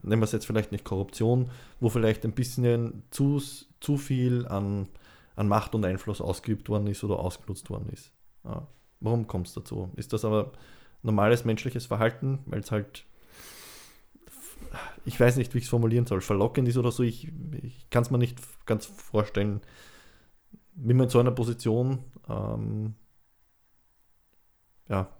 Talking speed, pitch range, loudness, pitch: 160 wpm, 100-125 Hz, -28 LUFS, 110 Hz